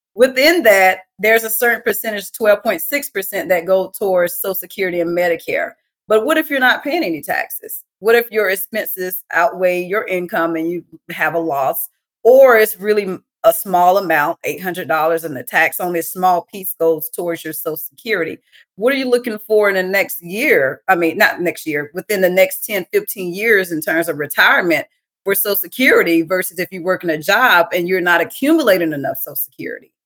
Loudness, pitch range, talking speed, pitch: -16 LUFS, 175-225 Hz, 190 wpm, 190 Hz